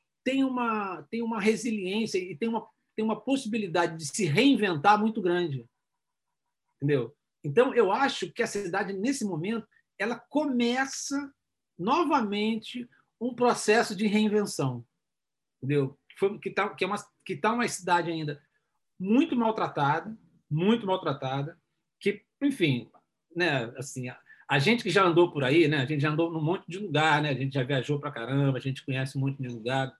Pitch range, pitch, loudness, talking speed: 150-225 Hz, 190 Hz, -28 LUFS, 165 wpm